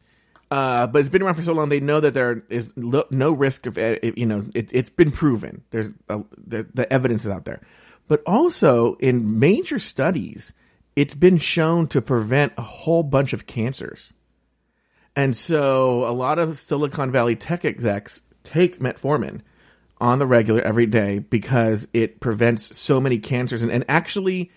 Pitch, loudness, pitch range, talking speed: 125 Hz, -21 LUFS, 115-150 Hz, 175 wpm